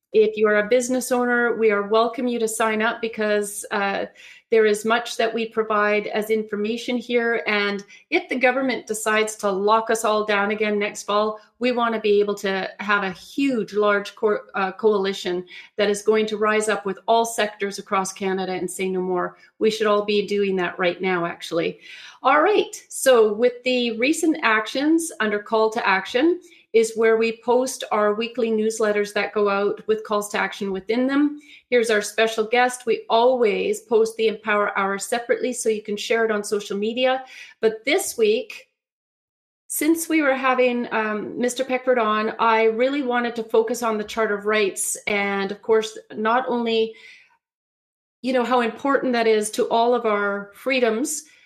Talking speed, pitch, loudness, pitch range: 185 wpm, 220 Hz, -21 LUFS, 210-245 Hz